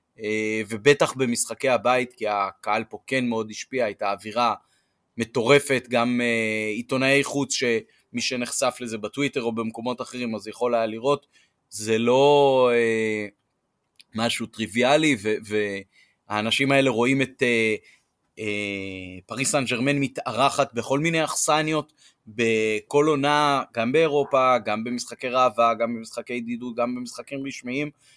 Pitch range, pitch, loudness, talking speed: 110-135 Hz, 120 Hz, -23 LUFS, 130 wpm